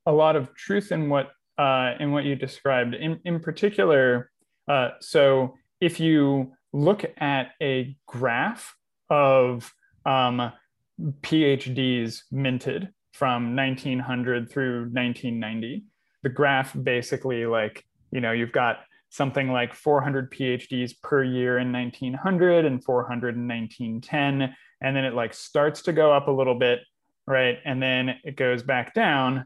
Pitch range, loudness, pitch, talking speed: 125-145 Hz, -24 LUFS, 130 Hz, 140 wpm